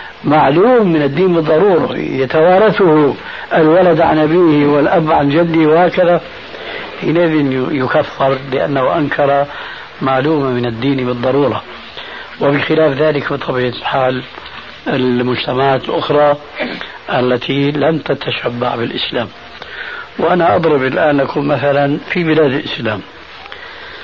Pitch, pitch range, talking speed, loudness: 145 Hz, 135-160 Hz, 95 wpm, -13 LUFS